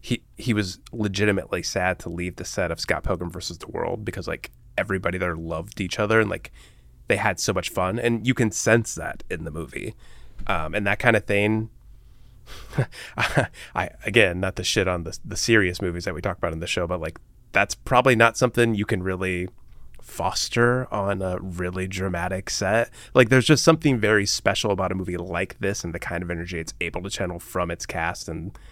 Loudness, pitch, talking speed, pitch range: -24 LUFS, 100 Hz, 205 wpm, 90-115 Hz